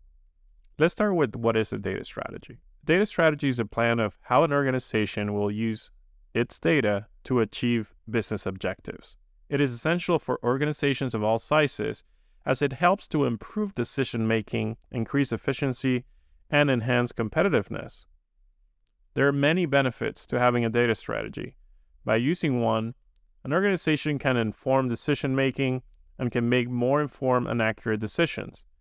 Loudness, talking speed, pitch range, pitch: -26 LUFS, 150 wpm, 110-140 Hz, 120 Hz